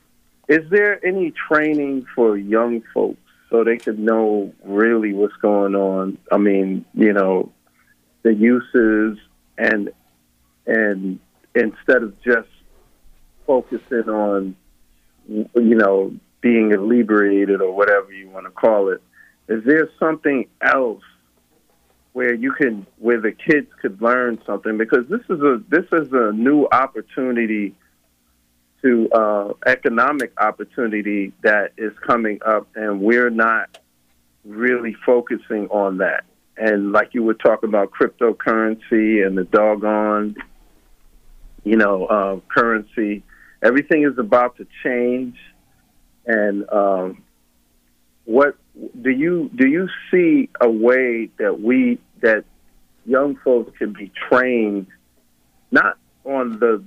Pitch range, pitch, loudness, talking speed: 95-120 Hz, 105 Hz, -18 LUFS, 120 wpm